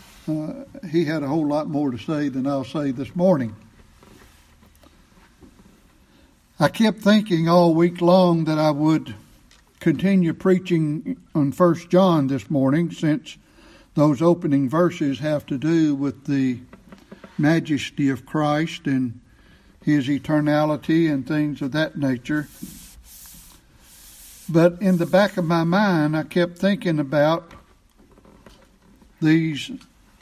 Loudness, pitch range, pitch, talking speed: -21 LUFS, 140-170 Hz, 155 Hz, 125 wpm